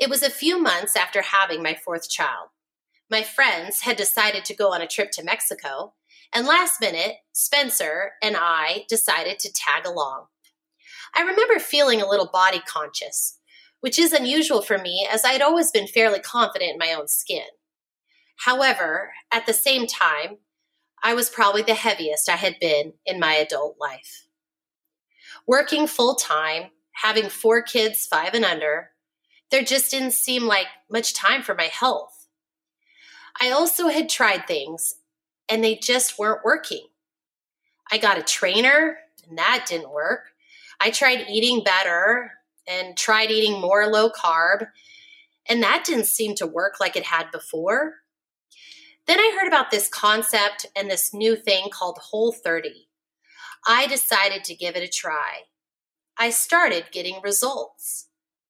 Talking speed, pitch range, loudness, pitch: 155 wpm, 195-295 Hz, -21 LUFS, 225 Hz